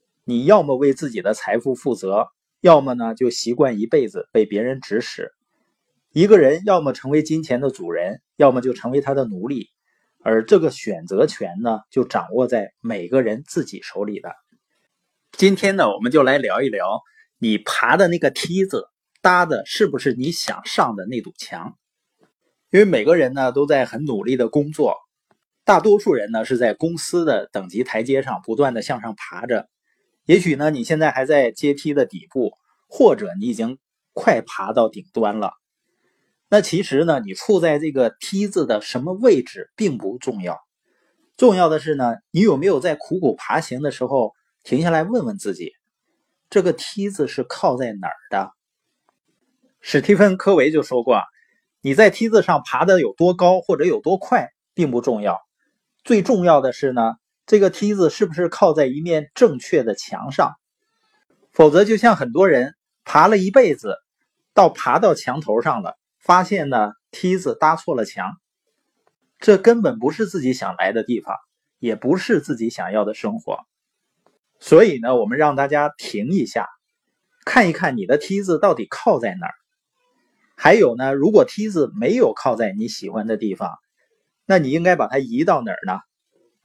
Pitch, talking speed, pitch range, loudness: 175 Hz, 250 characters per minute, 135-215 Hz, -18 LUFS